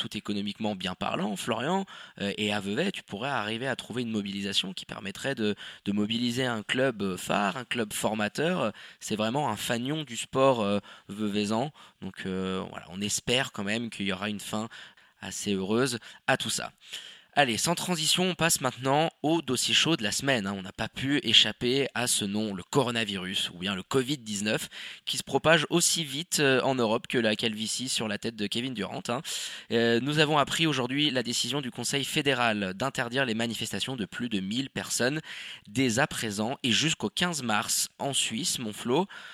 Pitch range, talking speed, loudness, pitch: 105-135 Hz, 185 wpm, -28 LUFS, 115 Hz